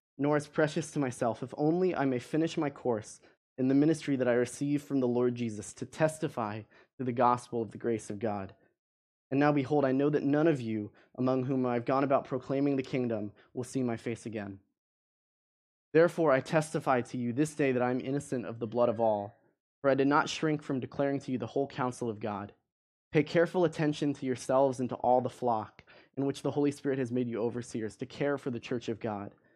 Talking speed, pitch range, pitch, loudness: 225 wpm, 120-145 Hz, 130 Hz, -31 LUFS